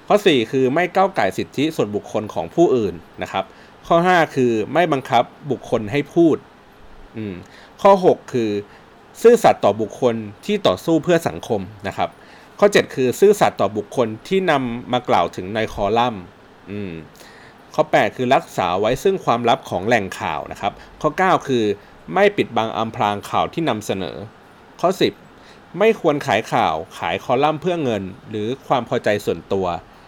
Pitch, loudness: 125 Hz, -19 LUFS